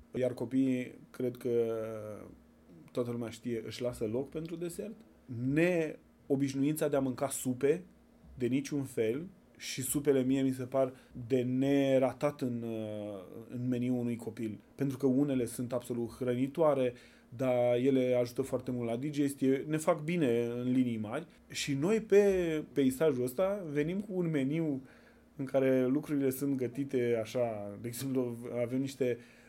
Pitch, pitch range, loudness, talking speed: 130 Hz, 120-140 Hz, -33 LUFS, 145 wpm